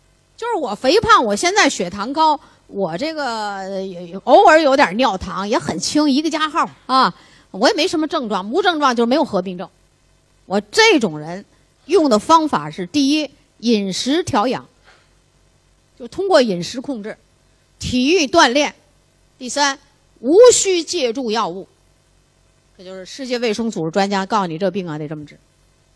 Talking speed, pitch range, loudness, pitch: 235 characters per minute, 195-315 Hz, -16 LUFS, 260 Hz